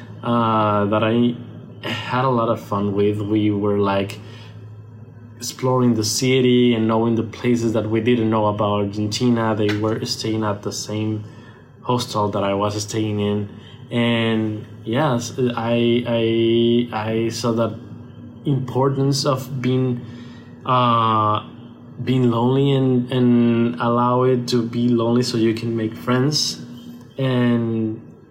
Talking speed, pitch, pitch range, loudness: 135 wpm, 115 Hz, 110-120 Hz, -20 LUFS